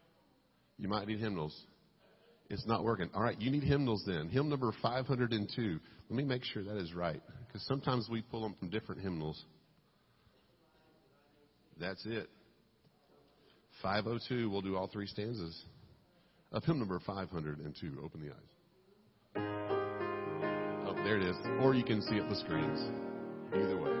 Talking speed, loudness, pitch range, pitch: 150 wpm, -37 LUFS, 95-120 Hz, 105 Hz